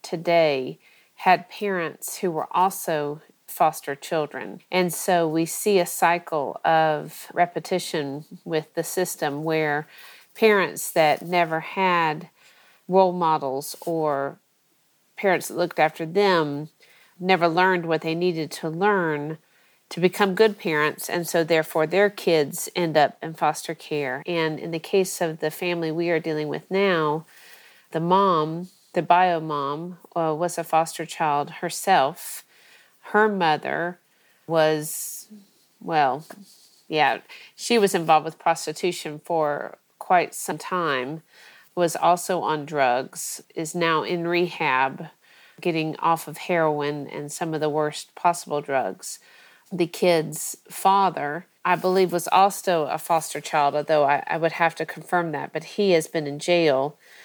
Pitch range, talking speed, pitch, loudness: 155-180 Hz, 140 wpm, 165 Hz, -23 LUFS